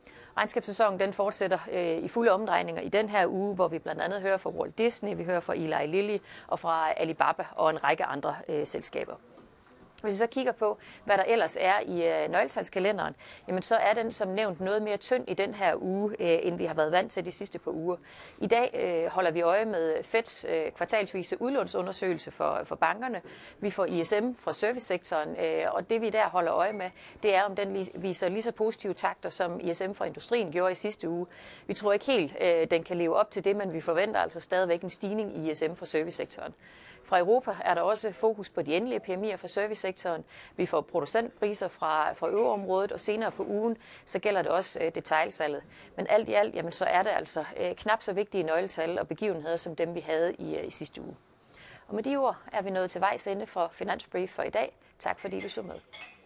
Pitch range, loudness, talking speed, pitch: 175-220 Hz, -29 LUFS, 215 wpm, 200 Hz